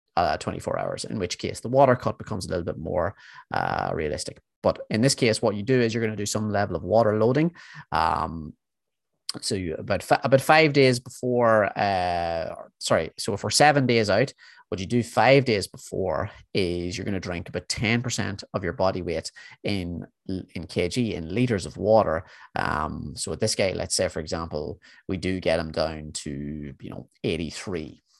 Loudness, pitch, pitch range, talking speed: -25 LUFS, 100 Hz, 85-120 Hz, 190 wpm